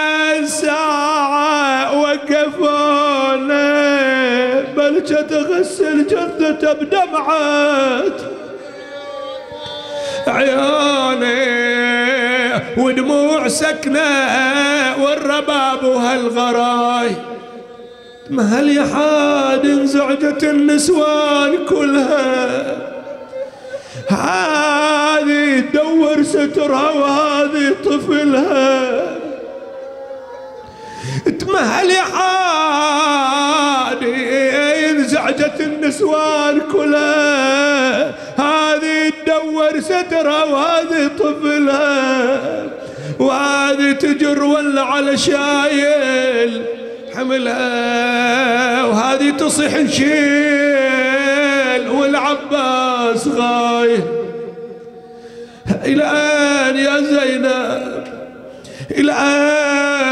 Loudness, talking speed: -14 LUFS, 45 wpm